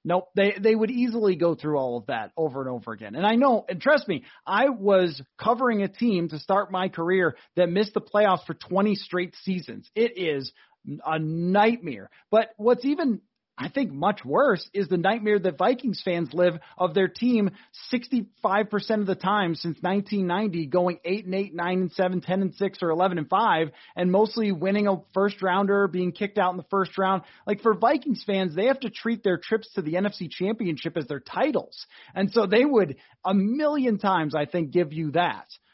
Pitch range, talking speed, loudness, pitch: 175-215 Hz, 200 wpm, -25 LUFS, 195 Hz